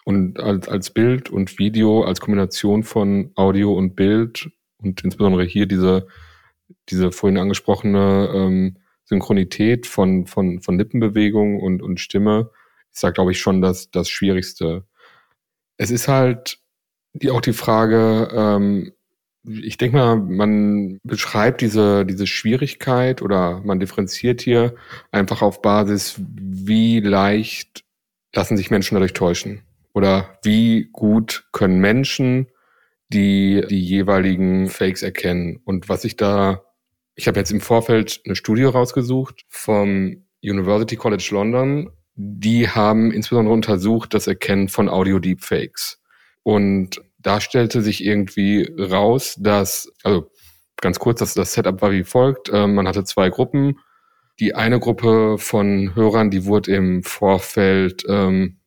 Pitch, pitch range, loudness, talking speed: 100 Hz, 95-115 Hz, -18 LUFS, 135 wpm